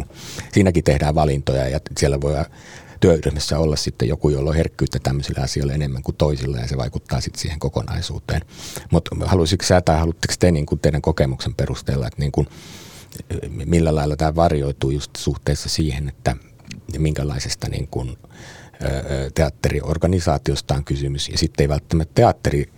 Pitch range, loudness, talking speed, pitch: 70-80 Hz, -20 LUFS, 150 wpm, 75 Hz